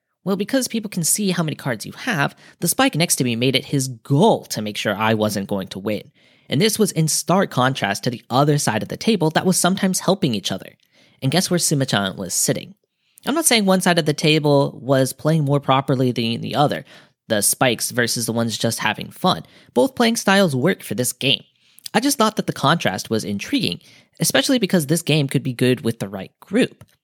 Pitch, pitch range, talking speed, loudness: 145 Hz, 120-180 Hz, 225 wpm, -19 LUFS